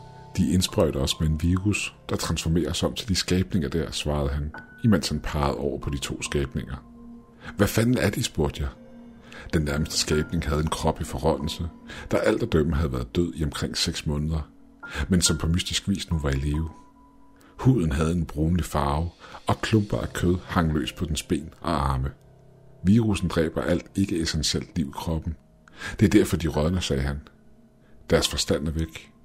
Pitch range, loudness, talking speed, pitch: 75-100 Hz, -25 LUFS, 190 wpm, 85 Hz